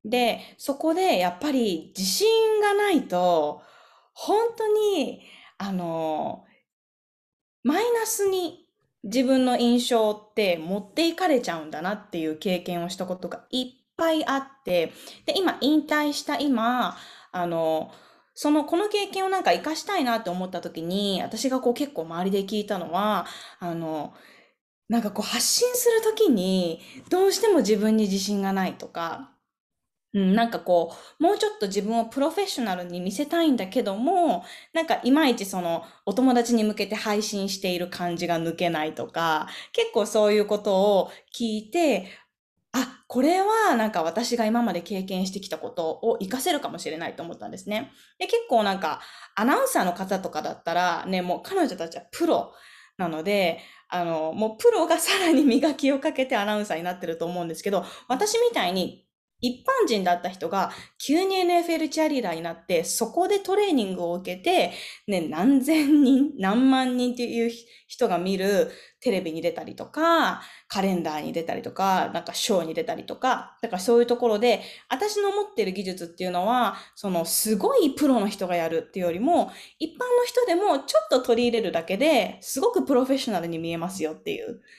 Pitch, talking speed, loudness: 230 Hz, 345 characters per minute, -25 LUFS